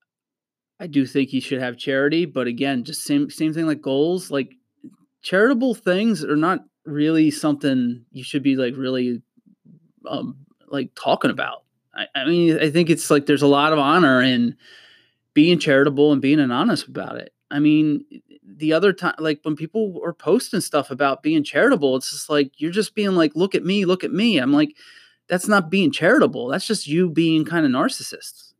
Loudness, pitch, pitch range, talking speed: -20 LUFS, 155 Hz, 140-195 Hz, 190 wpm